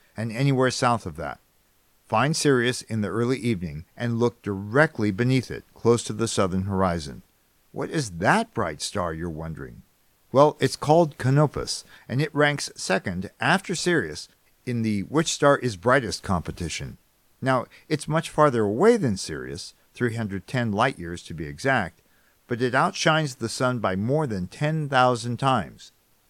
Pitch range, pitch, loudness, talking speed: 100-145 Hz, 120 Hz, -24 LUFS, 160 wpm